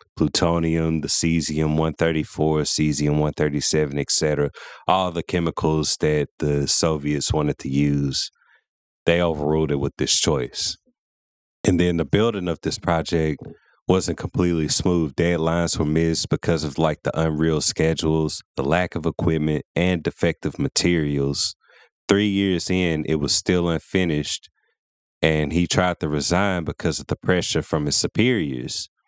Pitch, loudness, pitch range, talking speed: 80 Hz, -21 LUFS, 75-85 Hz, 140 wpm